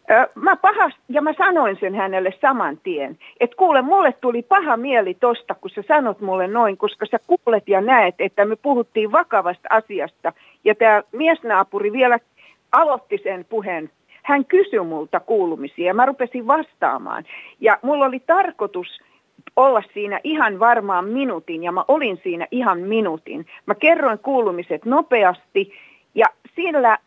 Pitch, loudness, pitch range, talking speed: 240 Hz, -19 LUFS, 195-295 Hz, 150 wpm